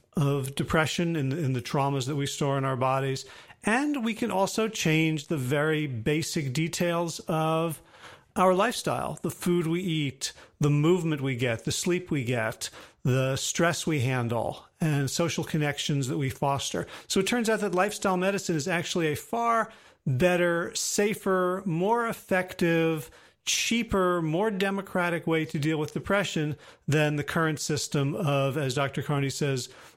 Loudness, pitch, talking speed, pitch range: -27 LUFS, 160 Hz, 160 wpm, 145-185 Hz